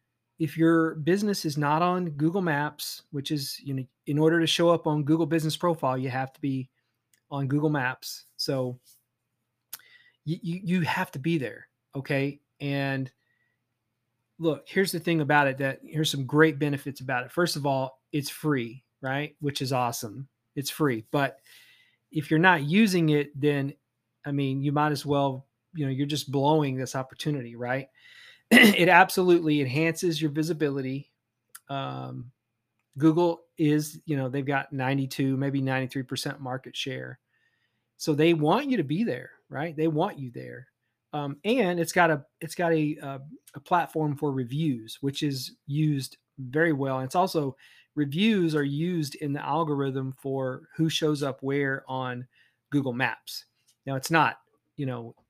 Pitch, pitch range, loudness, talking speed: 145 Hz, 130-160 Hz, -27 LUFS, 165 wpm